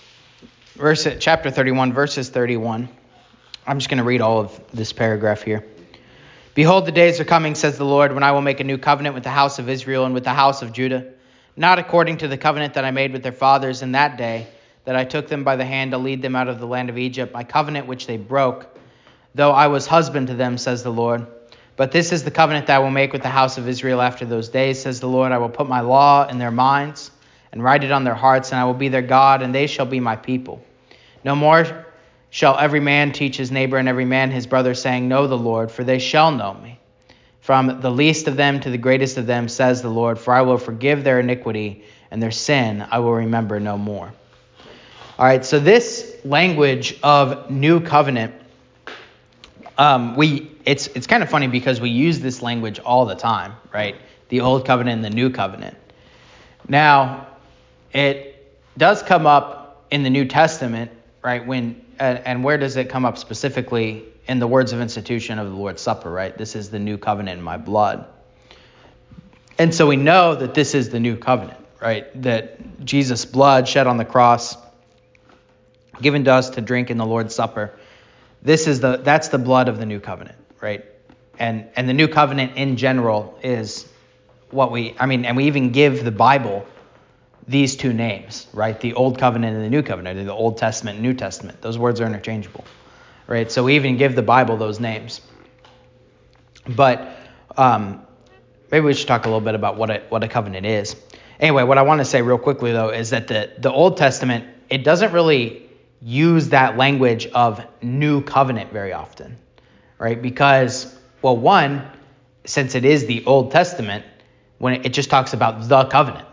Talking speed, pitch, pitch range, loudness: 200 wpm, 130 Hz, 115-140 Hz, -18 LUFS